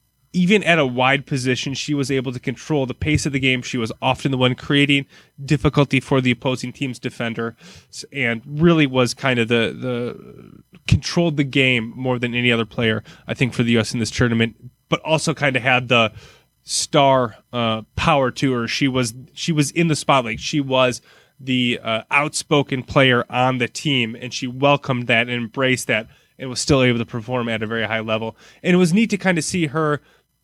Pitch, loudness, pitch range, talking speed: 130 Hz, -19 LUFS, 120-145 Hz, 205 wpm